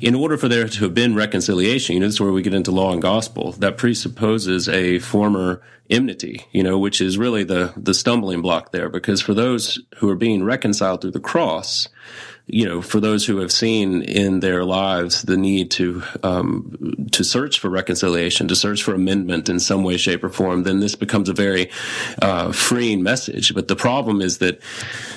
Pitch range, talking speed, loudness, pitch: 90-105 Hz, 205 wpm, -19 LUFS, 95 Hz